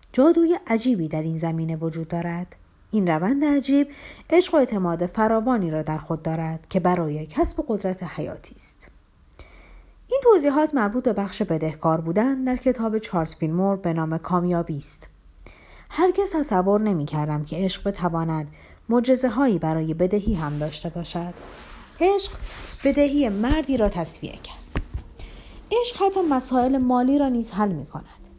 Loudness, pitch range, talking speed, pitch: -23 LUFS, 165-265 Hz, 140 wpm, 200 Hz